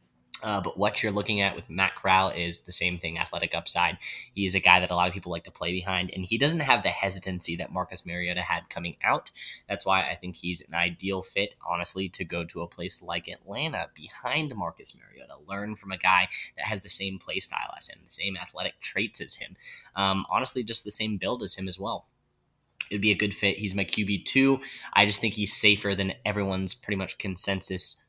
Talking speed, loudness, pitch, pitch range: 225 wpm, -25 LUFS, 95 Hz, 90-100 Hz